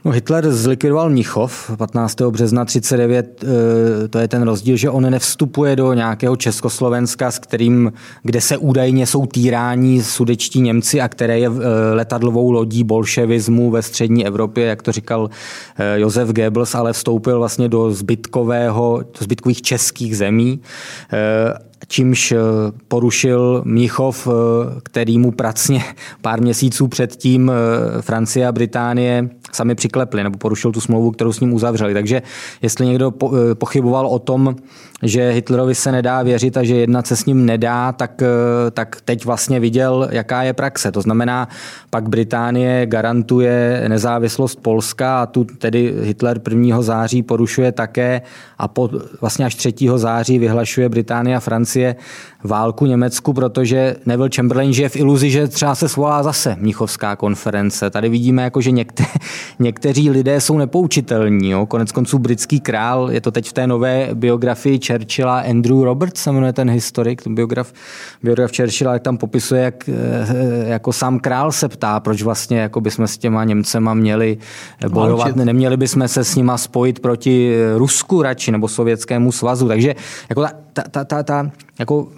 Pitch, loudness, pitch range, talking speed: 120 Hz, -16 LUFS, 115-130 Hz, 155 wpm